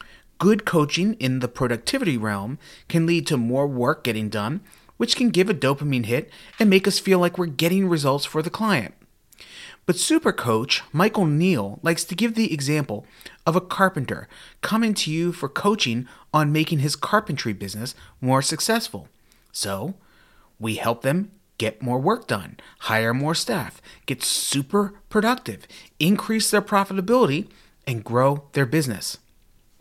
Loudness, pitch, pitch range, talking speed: -22 LUFS, 160 Hz, 130-195 Hz, 155 wpm